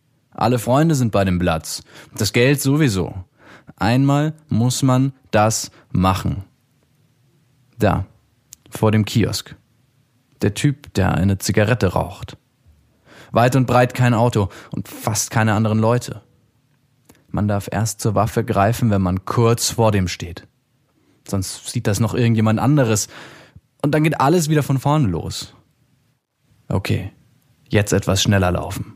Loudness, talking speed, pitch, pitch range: -19 LUFS, 135 wpm, 115 Hz, 100-135 Hz